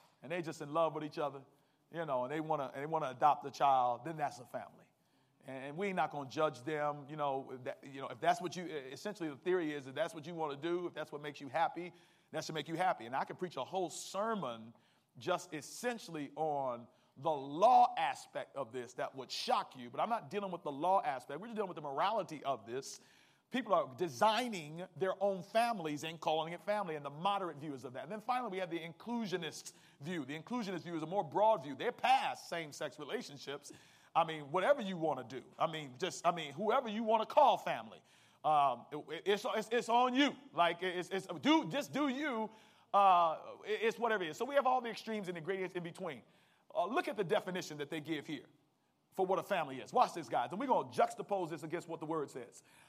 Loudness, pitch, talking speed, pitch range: -37 LUFS, 175 Hz, 235 wpm, 155-210 Hz